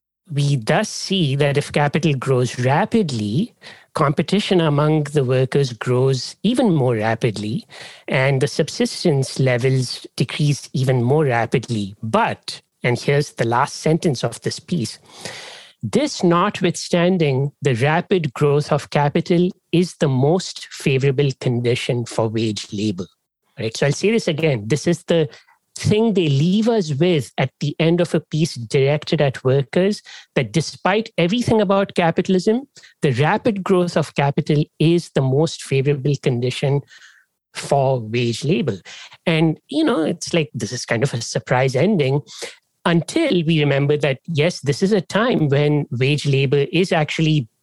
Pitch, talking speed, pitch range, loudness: 150 Hz, 145 wpm, 135-175 Hz, -19 LUFS